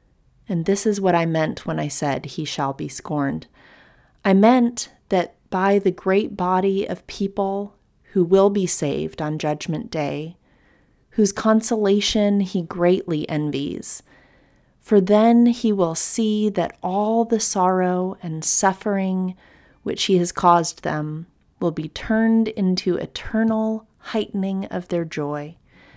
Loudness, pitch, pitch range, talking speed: -21 LUFS, 190 Hz, 165-210 Hz, 135 wpm